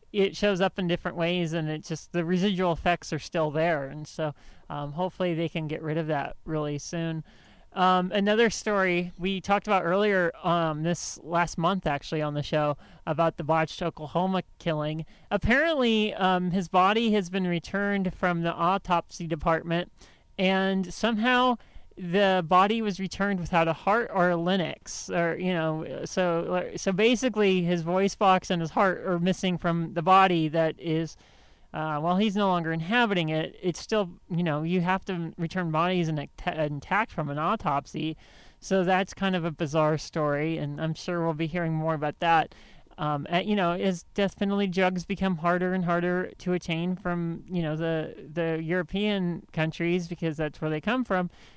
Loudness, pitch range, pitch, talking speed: -27 LUFS, 160-190 Hz, 175 Hz, 180 wpm